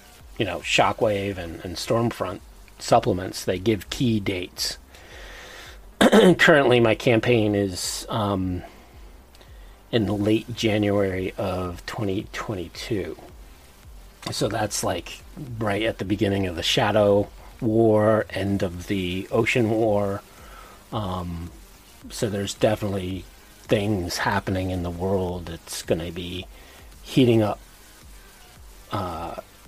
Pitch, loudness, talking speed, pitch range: 100 Hz, -23 LUFS, 105 wpm, 90-110 Hz